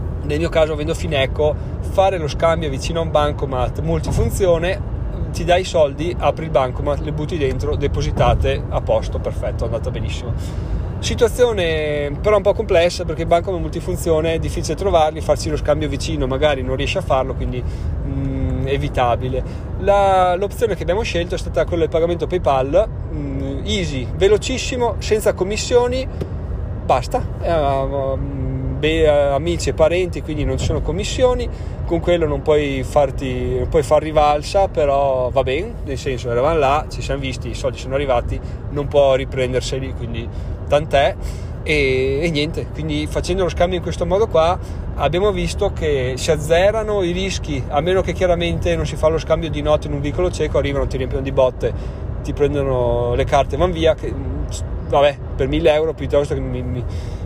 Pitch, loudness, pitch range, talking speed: 140 Hz, -19 LUFS, 125-160 Hz, 170 wpm